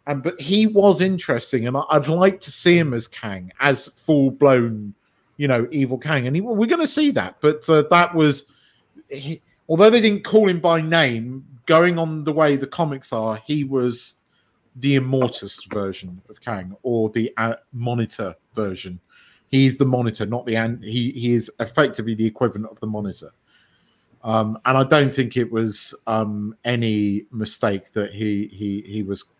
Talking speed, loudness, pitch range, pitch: 180 wpm, -20 LUFS, 110-150 Hz, 125 Hz